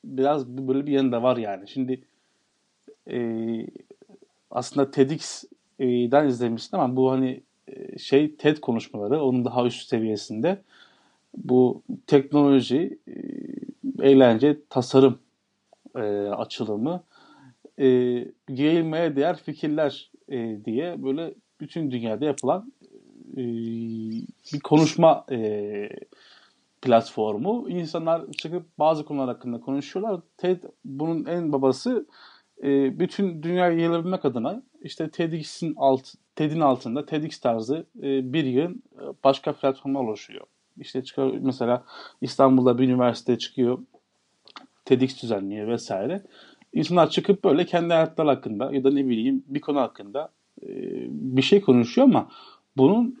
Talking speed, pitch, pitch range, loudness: 115 wpm, 135 Hz, 125-165 Hz, -24 LUFS